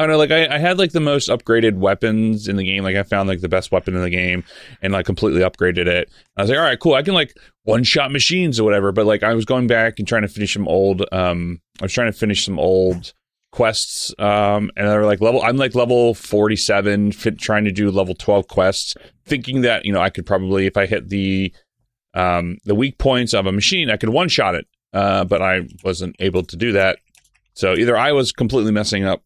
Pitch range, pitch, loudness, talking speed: 95-115 Hz, 105 Hz, -17 LUFS, 245 wpm